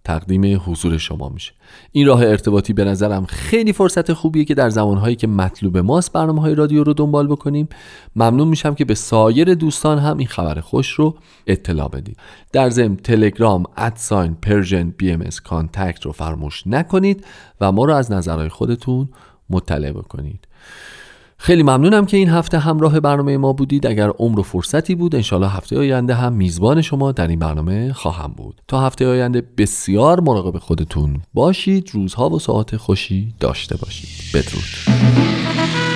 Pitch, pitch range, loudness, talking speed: 110 Hz, 90-145 Hz, -16 LUFS, 160 wpm